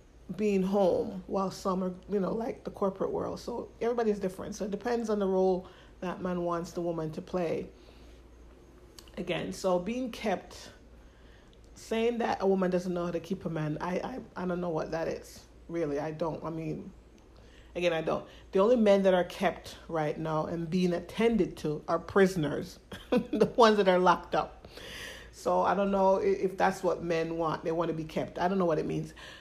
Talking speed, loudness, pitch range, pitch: 200 wpm, -30 LUFS, 165-195 Hz, 180 Hz